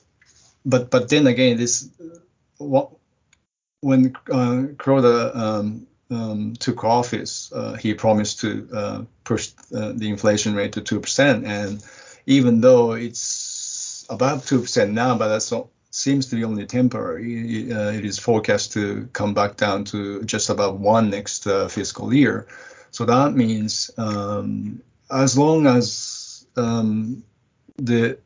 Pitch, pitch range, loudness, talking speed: 115 Hz, 105-125 Hz, -21 LUFS, 140 wpm